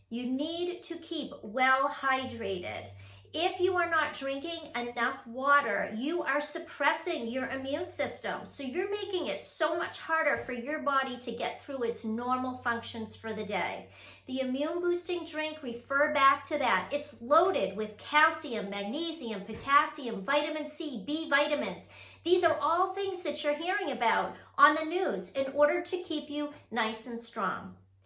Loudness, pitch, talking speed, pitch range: -31 LUFS, 285 Hz, 160 wpm, 240-320 Hz